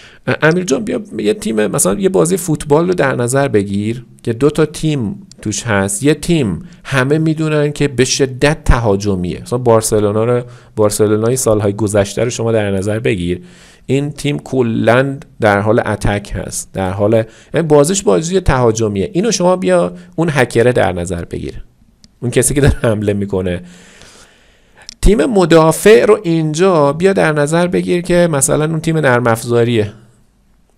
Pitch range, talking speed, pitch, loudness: 105-155 Hz, 150 wpm, 125 Hz, -14 LUFS